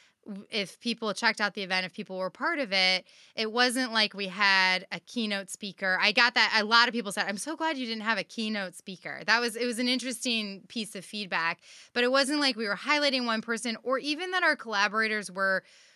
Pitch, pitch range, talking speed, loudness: 220 Hz, 200-245 Hz, 230 wpm, -27 LUFS